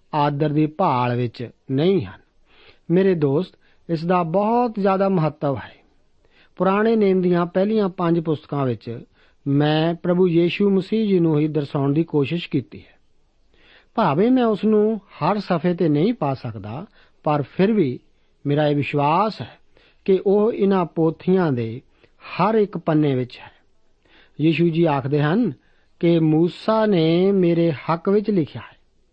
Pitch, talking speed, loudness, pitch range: 170 Hz, 145 wpm, -20 LUFS, 145-190 Hz